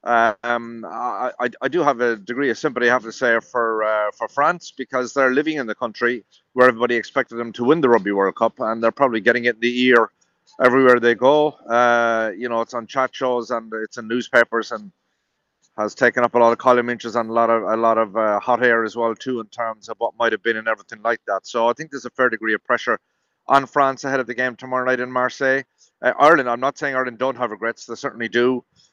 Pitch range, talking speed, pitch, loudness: 115-130 Hz, 250 wpm, 120 Hz, -19 LUFS